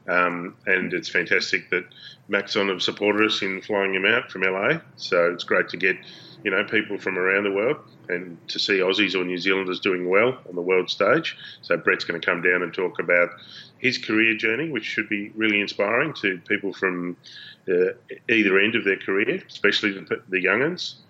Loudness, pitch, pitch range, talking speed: -22 LUFS, 100 Hz, 90-110 Hz, 200 wpm